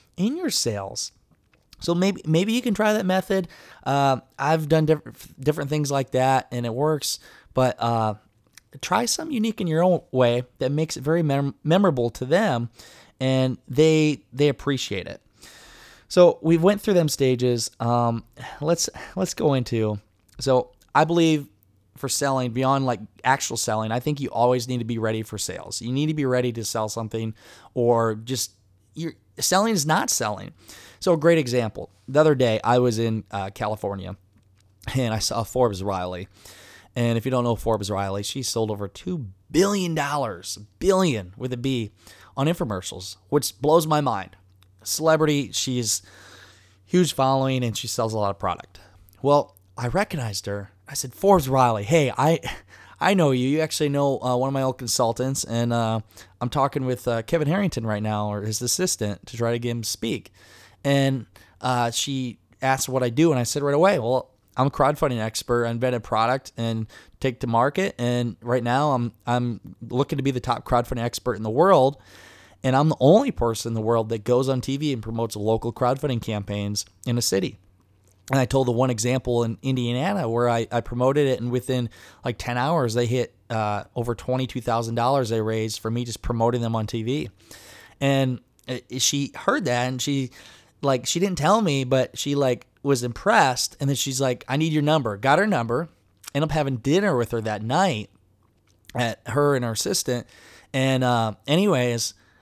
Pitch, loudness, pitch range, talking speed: 125 Hz, -23 LUFS, 110-140 Hz, 185 wpm